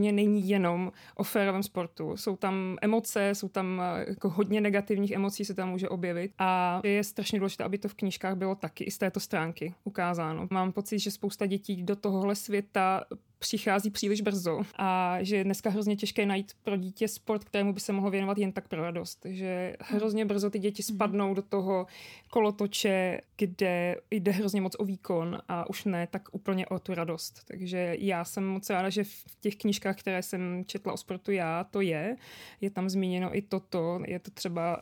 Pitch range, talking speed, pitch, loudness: 185-205 Hz, 190 wpm, 195 Hz, -31 LUFS